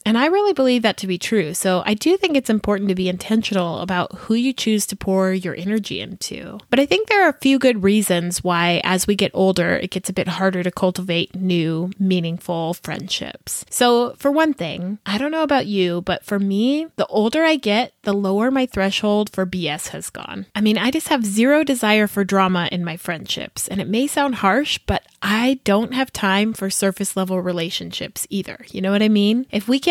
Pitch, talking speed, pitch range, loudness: 200 Hz, 215 wpm, 185-240 Hz, -19 LUFS